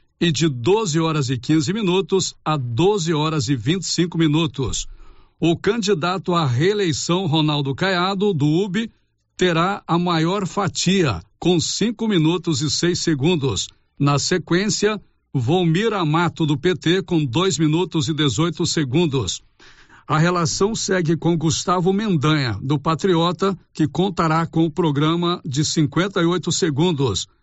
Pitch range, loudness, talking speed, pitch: 155-180 Hz, -20 LUFS, 140 wpm, 165 Hz